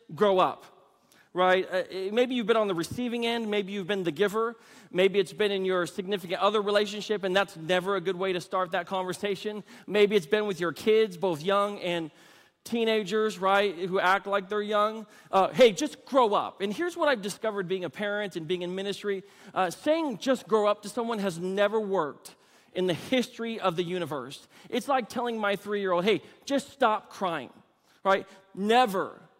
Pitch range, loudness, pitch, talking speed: 185-220 Hz, -28 LUFS, 200 Hz, 195 wpm